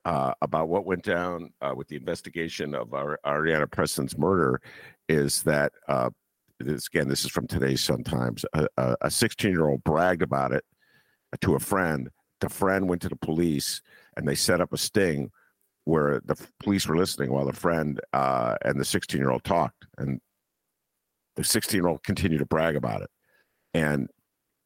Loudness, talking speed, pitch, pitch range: -27 LUFS, 180 wpm, 80 Hz, 70-90 Hz